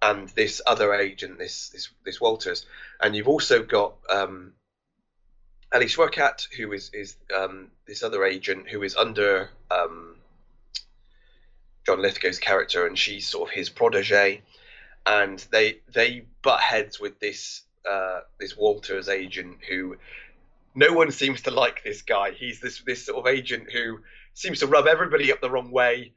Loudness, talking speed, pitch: -24 LUFS, 160 wpm, 125 Hz